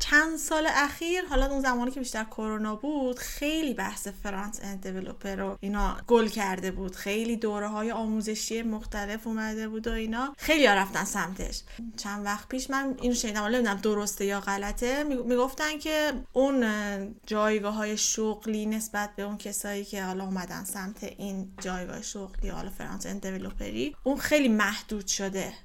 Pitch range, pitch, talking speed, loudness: 200-250 Hz, 215 Hz, 155 wpm, -29 LUFS